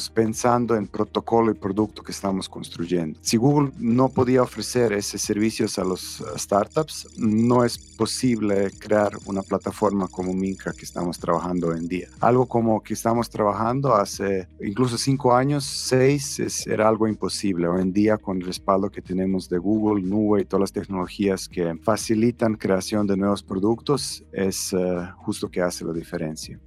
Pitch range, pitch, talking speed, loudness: 95-115 Hz, 100 Hz, 165 wpm, -23 LUFS